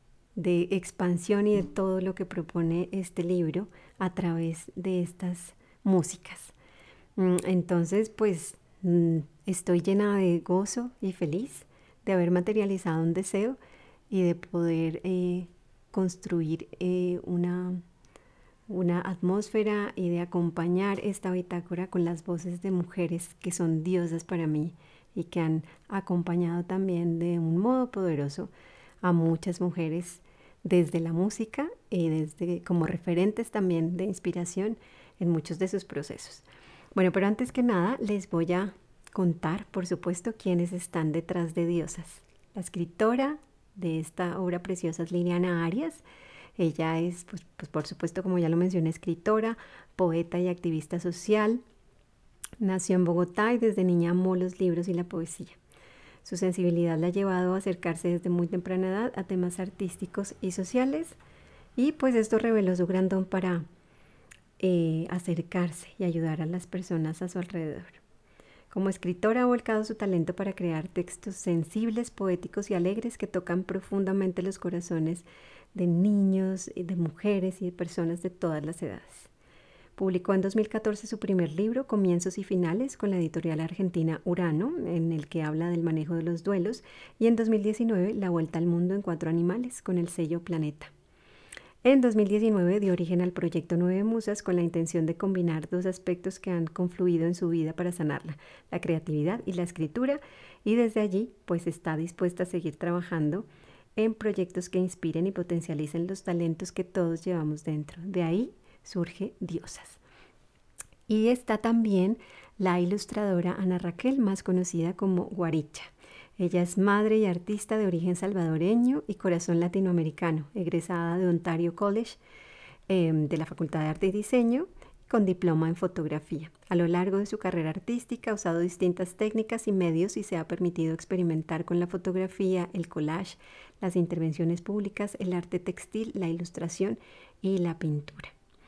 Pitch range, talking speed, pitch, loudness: 170-195 Hz, 155 wpm, 180 Hz, -29 LUFS